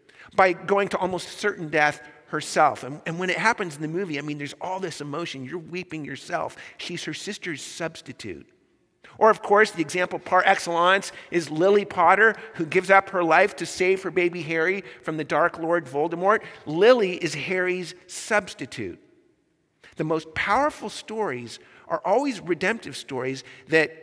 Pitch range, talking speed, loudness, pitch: 160-195 Hz, 165 wpm, -24 LUFS, 180 Hz